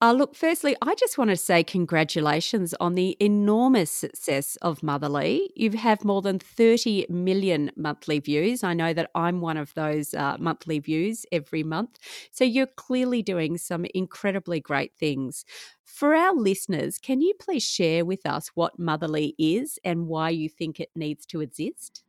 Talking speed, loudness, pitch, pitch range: 170 wpm, -25 LUFS, 175 Hz, 160-225 Hz